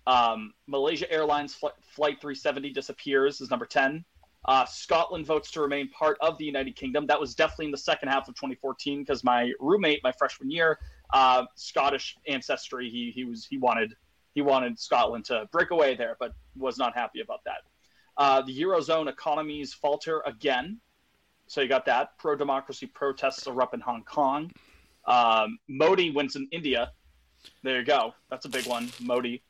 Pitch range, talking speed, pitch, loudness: 130-155 Hz, 175 wpm, 140 Hz, -27 LUFS